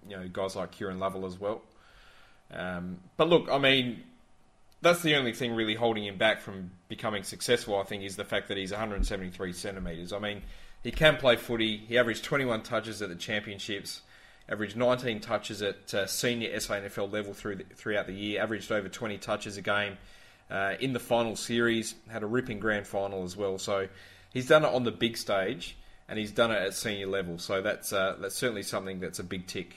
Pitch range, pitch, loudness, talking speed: 95-115 Hz, 105 Hz, -30 LUFS, 215 wpm